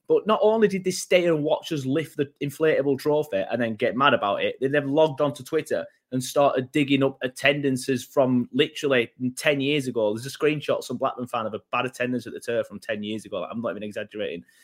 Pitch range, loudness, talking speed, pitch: 125-150 Hz, -24 LUFS, 225 wpm, 140 Hz